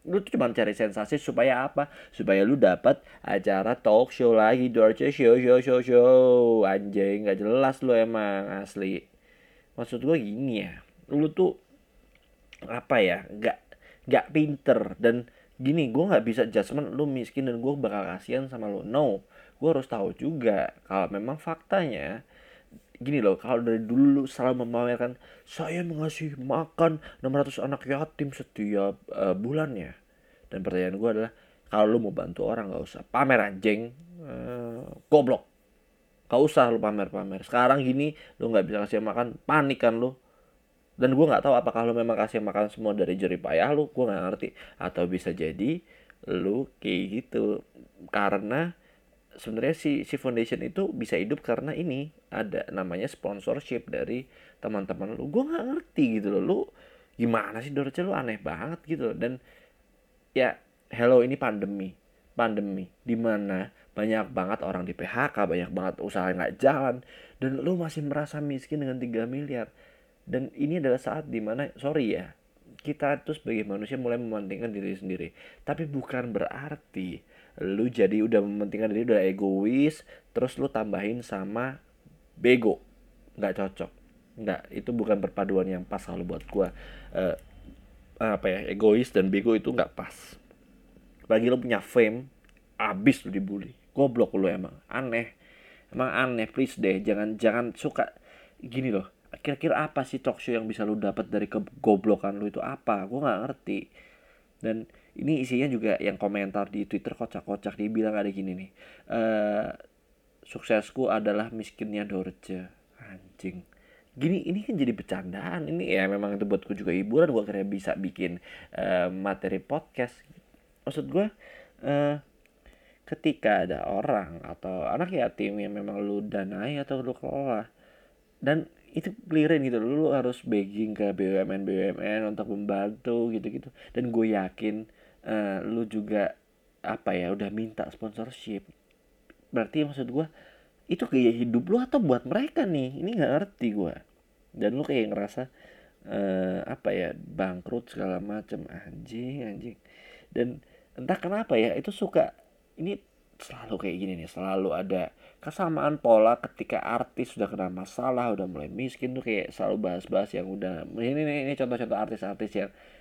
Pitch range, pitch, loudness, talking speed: 100-140 Hz, 115 Hz, -28 LUFS, 150 wpm